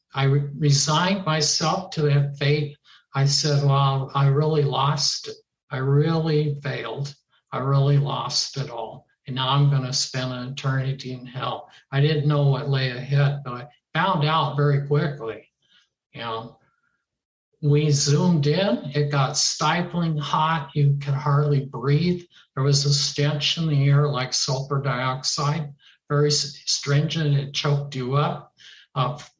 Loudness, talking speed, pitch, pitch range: -22 LUFS, 150 wpm, 145 Hz, 135-150 Hz